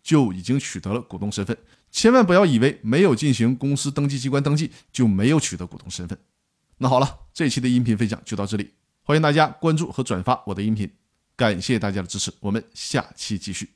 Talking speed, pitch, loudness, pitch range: 340 characters per minute, 120 Hz, -22 LUFS, 100-140 Hz